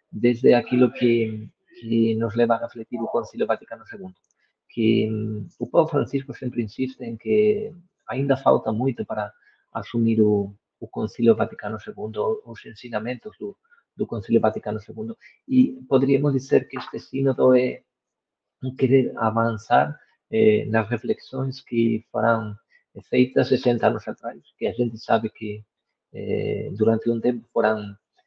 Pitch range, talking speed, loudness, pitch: 110-135 Hz, 135 wpm, -23 LUFS, 120 Hz